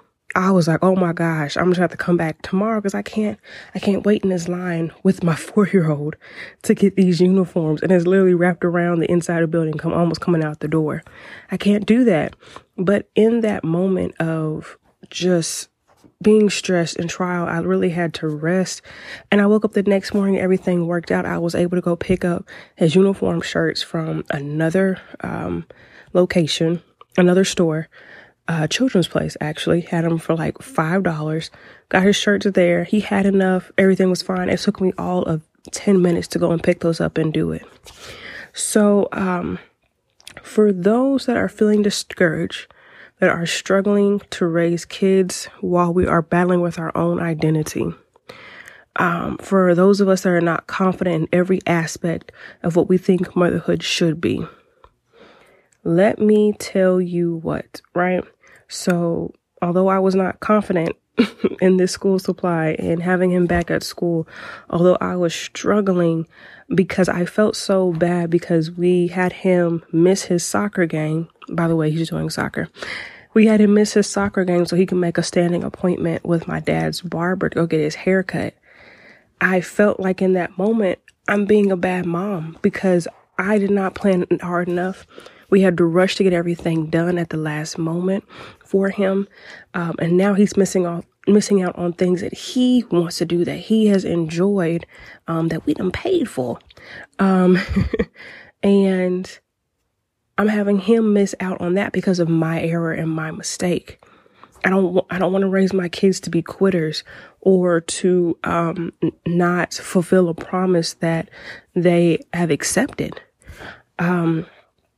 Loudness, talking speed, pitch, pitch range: -19 LUFS, 175 wpm, 180 Hz, 170-195 Hz